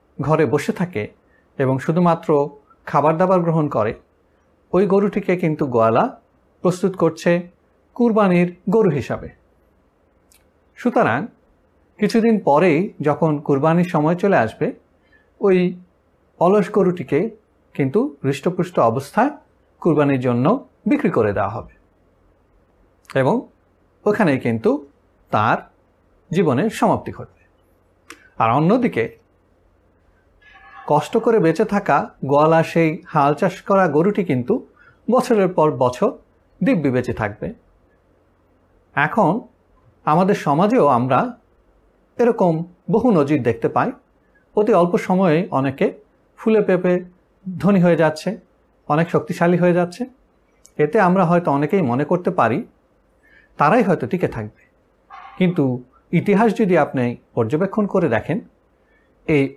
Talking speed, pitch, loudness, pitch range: 105 wpm, 155 Hz, -18 LUFS, 115-190 Hz